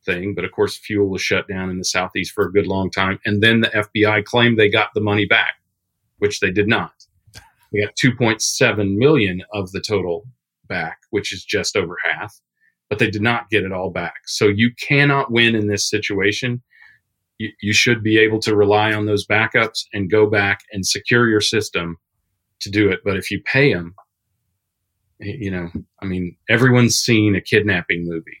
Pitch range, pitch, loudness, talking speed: 95-110 Hz, 105 Hz, -18 LUFS, 195 wpm